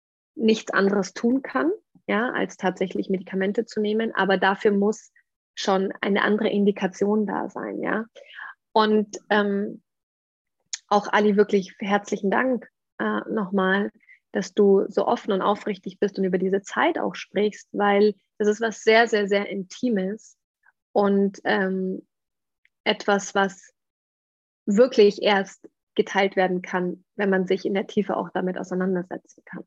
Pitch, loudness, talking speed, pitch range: 205 Hz, -23 LUFS, 140 wpm, 195-210 Hz